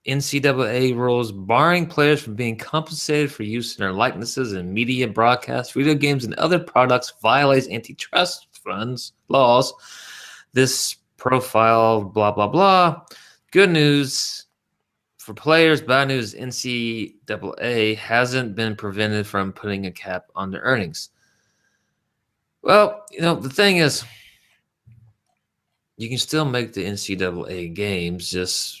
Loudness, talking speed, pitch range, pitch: -20 LUFS, 125 wpm, 110-145 Hz, 125 Hz